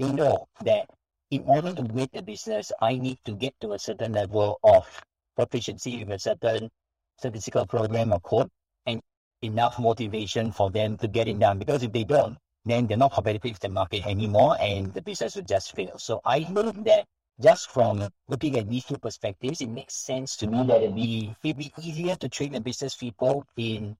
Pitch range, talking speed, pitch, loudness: 110-135 Hz, 200 wpm, 120 Hz, -26 LUFS